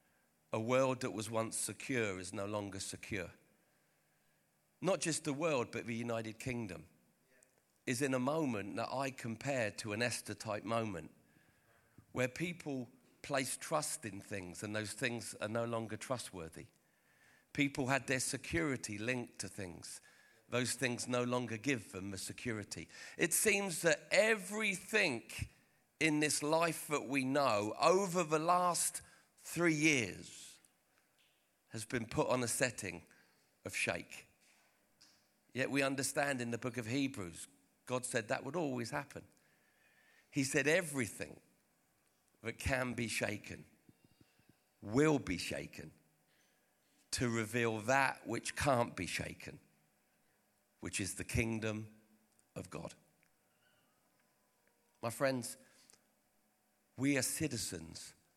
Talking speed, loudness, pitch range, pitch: 125 wpm, -37 LUFS, 105-140 Hz, 120 Hz